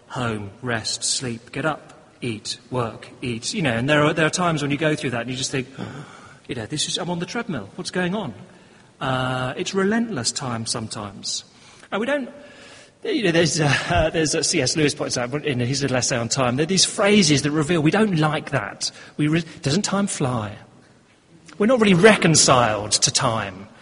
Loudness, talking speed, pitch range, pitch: -21 LUFS, 205 wpm, 125-175 Hz, 145 Hz